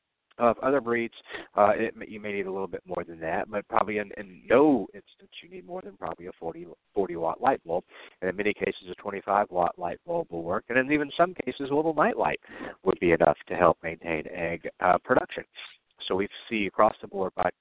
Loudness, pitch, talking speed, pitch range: -27 LUFS, 105 Hz, 225 wpm, 95-140 Hz